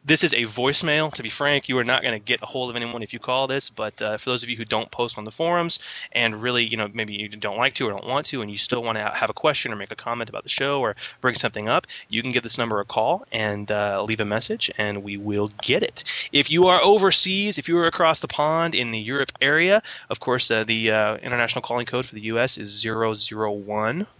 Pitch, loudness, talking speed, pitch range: 120 Hz, -22 LUFS, 270 wpm, 110-145 Hz